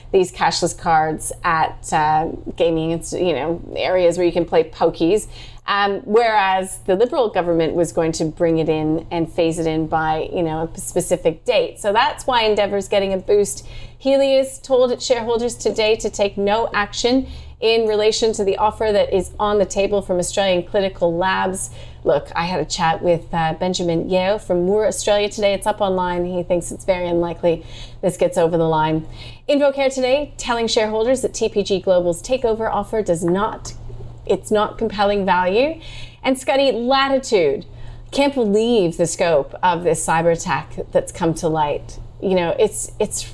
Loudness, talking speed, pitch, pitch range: -19 LUFS, 170 wpm, 190 Hz, 170-220 Hz